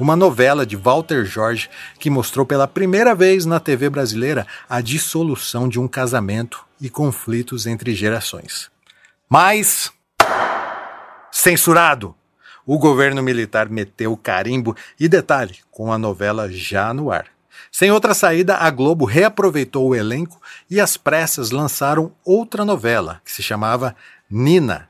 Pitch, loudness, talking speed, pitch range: 135 Hz, -17 LUFS, 135 wpm, 115-165 Hz